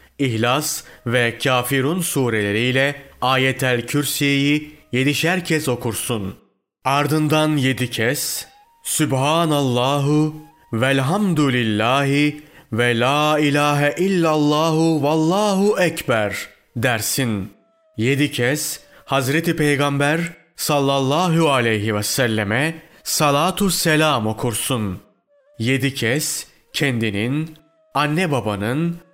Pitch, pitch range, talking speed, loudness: 145 Hz, 125-155 Hz, 75 wpm, -19 LUFS